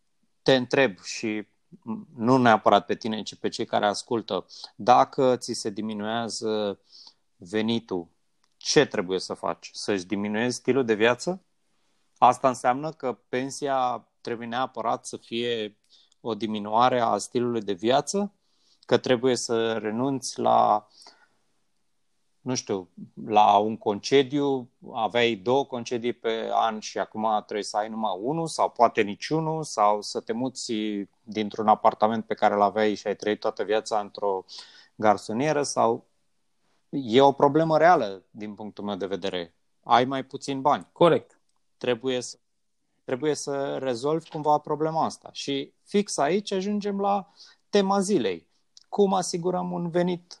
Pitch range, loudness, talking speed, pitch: 105-145 Hz, -25 LUFS, 140 wpm, 120 Hz